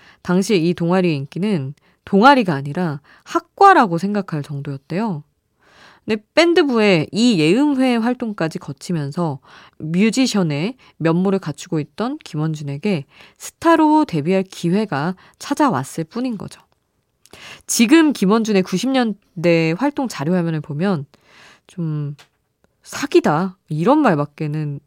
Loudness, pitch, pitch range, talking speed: -18 LUFS, 185 Hz, 155-235 Hz, 260 characters per minute